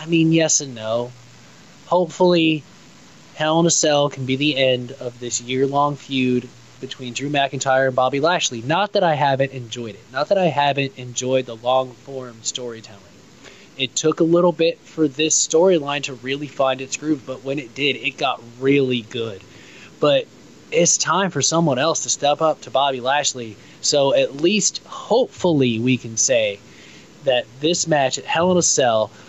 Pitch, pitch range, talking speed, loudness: 135 Hz, 125-155 Hz, 180 wpm, -19 LUFS